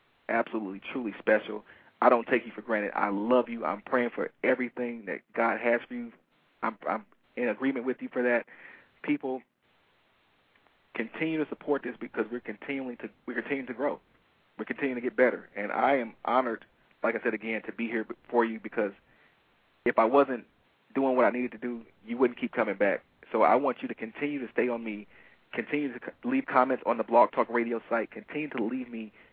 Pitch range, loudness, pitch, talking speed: 115-135 Hz, -30 LUFS, 125 Hz, 205 wpm